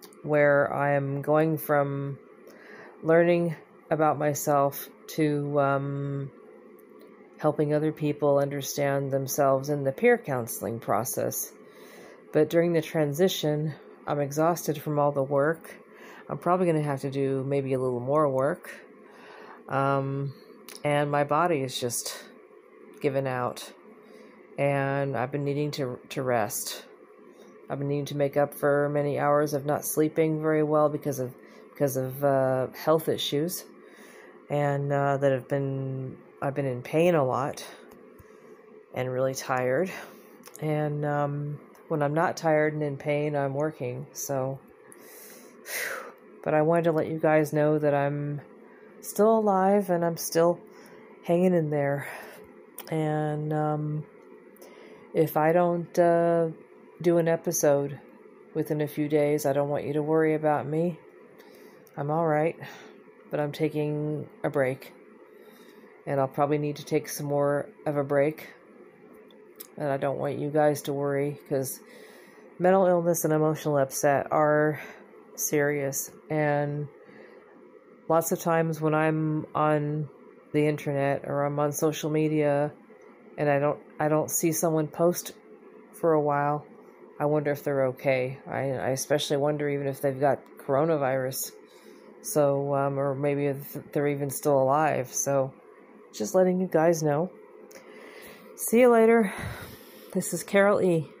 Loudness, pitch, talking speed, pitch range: -27 LUFS, 145 Hz, 140 wpm, 140-155 Hz